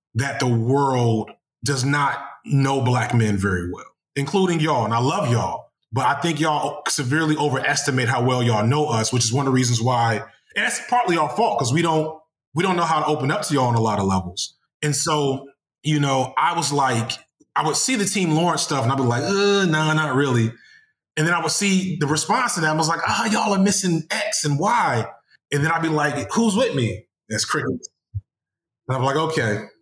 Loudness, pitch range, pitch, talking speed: -20 LUFS, 125-165 Hz, 145 Hz, 230 wpm